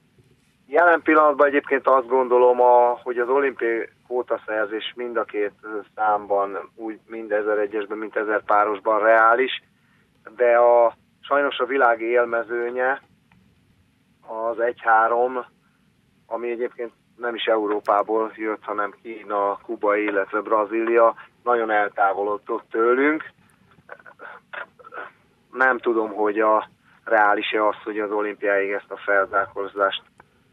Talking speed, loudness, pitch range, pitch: 110 wpm, -21 LUFS, 105-125 Hz, 115 Hz